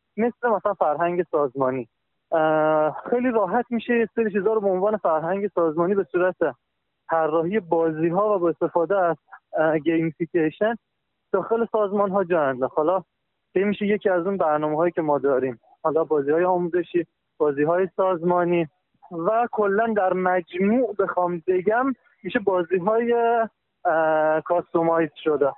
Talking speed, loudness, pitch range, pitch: 130 wpm, -23 LUFS, 165-205 Hz, 180 Hz